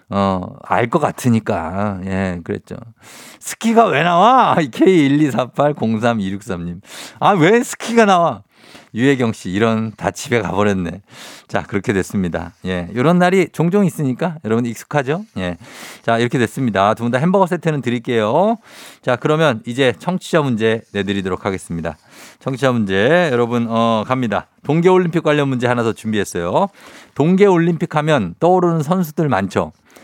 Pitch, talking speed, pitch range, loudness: 120 Hz, 305 characters per minute, 100-165 Hz, -17 LUFS